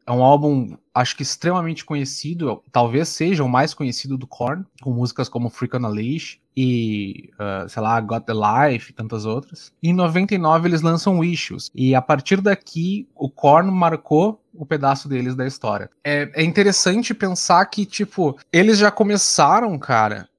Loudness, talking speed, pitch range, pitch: -19 LUFS, 170 wpm, 125-175 Hz, 145 Hz